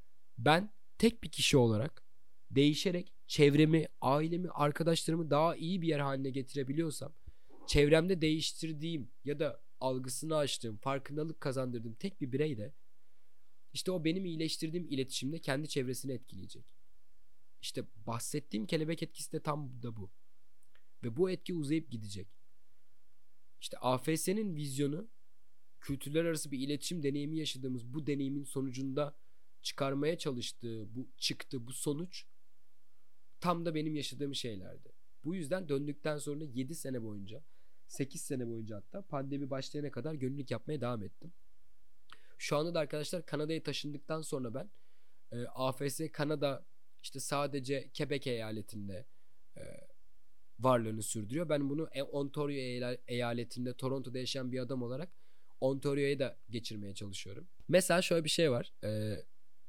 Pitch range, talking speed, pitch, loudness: 125-155 Hz, 125 wpm, 140 Hz, -36 LUFS